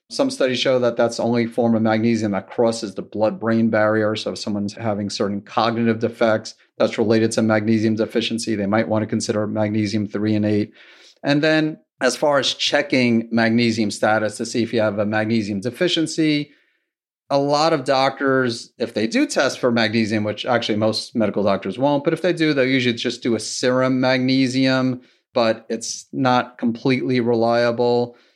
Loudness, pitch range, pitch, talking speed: -20 LUFS, 110-130 Hz, 115 Hz, 180 wpm